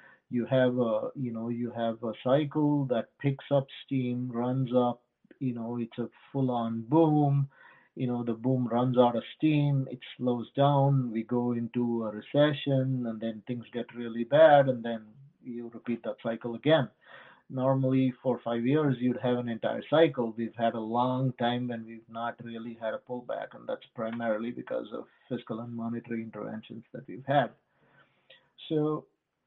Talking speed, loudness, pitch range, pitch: 170 wpm, -29 LUFS, 115-130 Hz, 120 Hz